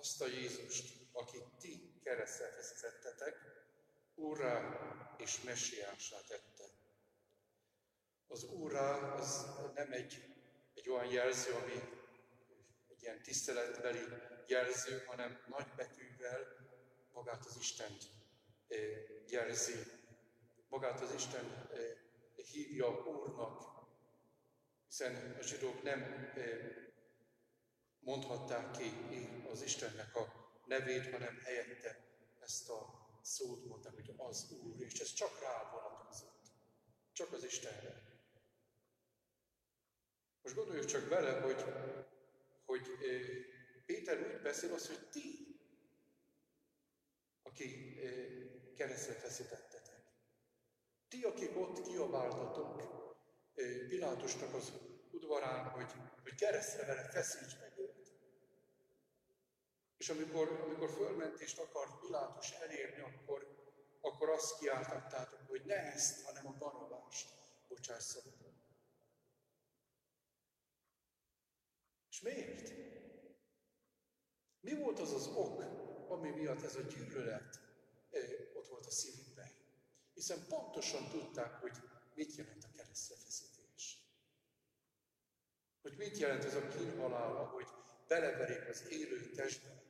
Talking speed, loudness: 100 wpm, -44 LUFS